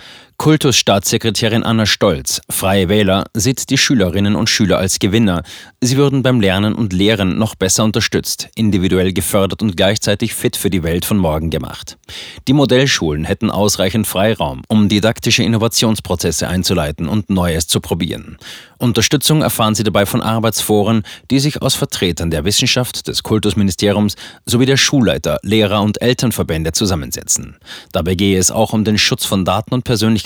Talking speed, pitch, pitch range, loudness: 155 wpm, 105 Hz, 95-115 Hz, -14 LUFS